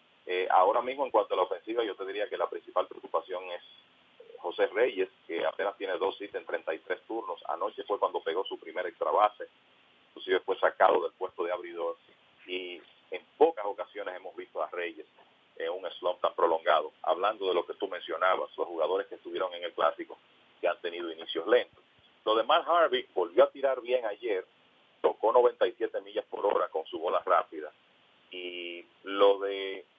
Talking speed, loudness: 190 wpm, -30 LUFS